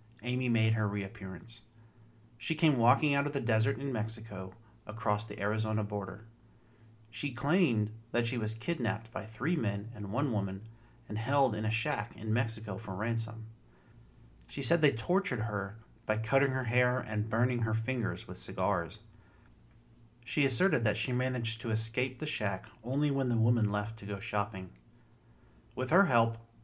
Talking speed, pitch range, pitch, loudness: 165 wpm, 105-125 Hz, 115 Hz, -32 LUFS